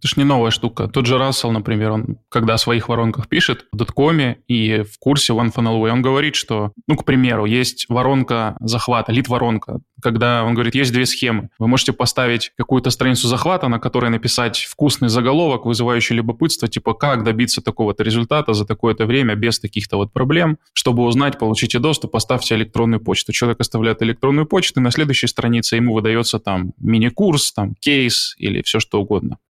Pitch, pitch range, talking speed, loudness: 120 Hz, 115-130 Hz, 180 wpm, -17 LUFS